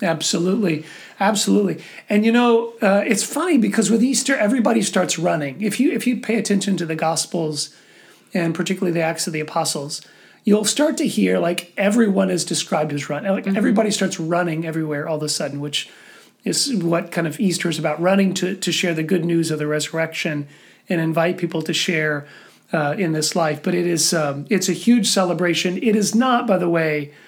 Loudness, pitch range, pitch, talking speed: -19 LUFS, 160-210 Hz, 180 Hz, 195 wpm